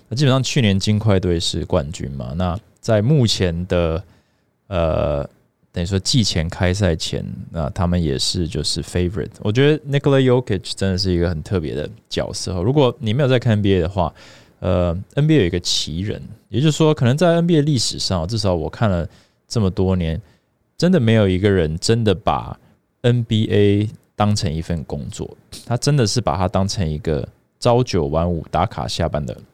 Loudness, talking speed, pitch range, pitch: -19 LUFS, 300 characters per minute, 90-120 Hz, 100 Hz